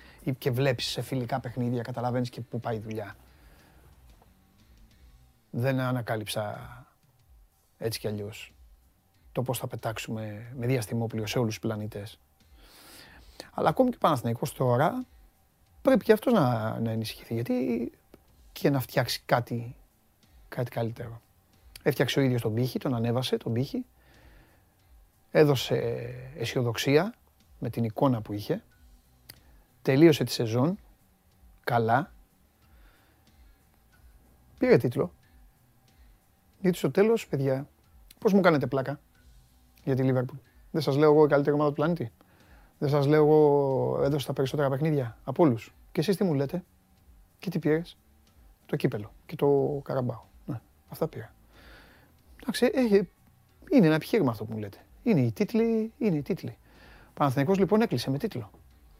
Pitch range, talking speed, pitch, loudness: 105-145 Hz, 135 wpm, 120 Hz, -27 LUFS